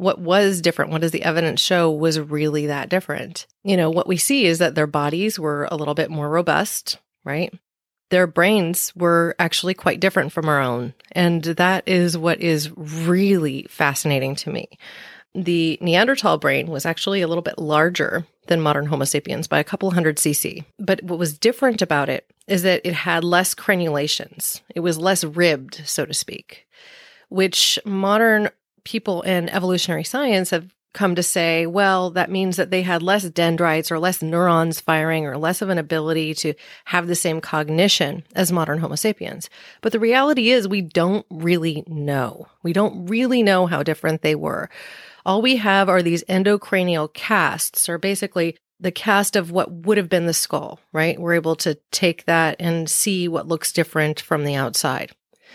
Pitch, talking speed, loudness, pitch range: 170 Hz, 180 wpm, -20 LUFS, 160-190 Hz